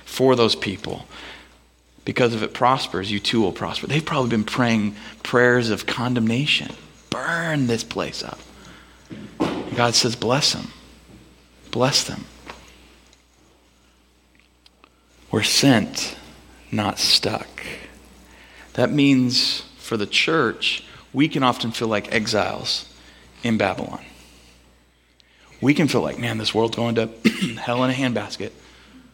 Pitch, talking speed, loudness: 110 Hz, 120 wpm, -21 LUFS